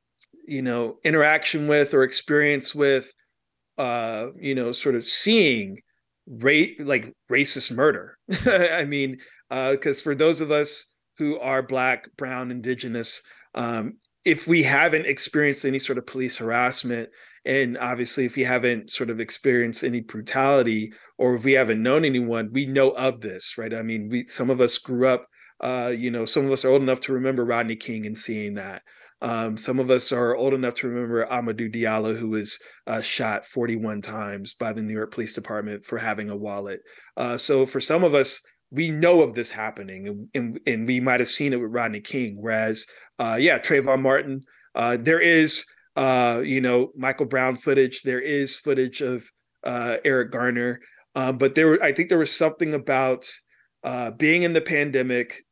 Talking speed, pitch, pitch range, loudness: 185 wpm, 130 Hz, 115-135 Hz, -23 LUFS